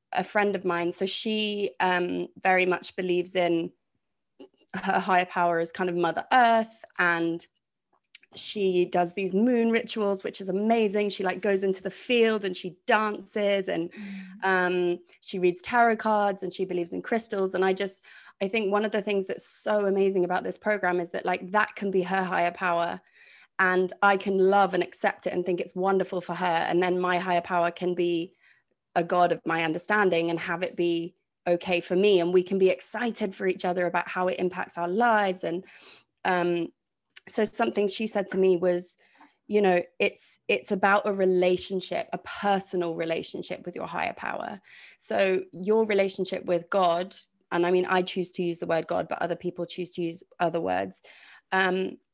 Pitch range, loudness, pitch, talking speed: 175-200 Hz, -26 LUFS, 185 Hz, 190 wpm